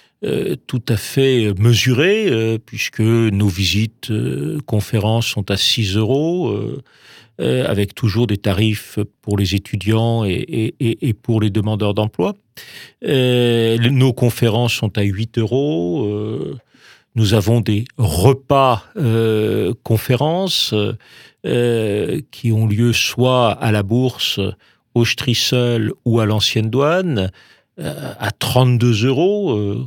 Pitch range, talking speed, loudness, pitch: 105-125 Hz, 125 wpm, -17 LUFS, 115 Hz